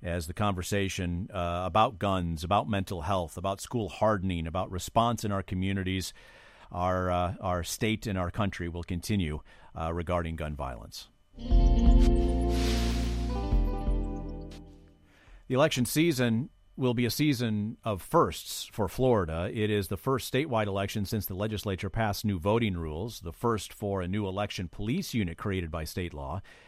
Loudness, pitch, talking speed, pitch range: -30 LUFS, 95 Hz, 150 wpm, 85-110 Hz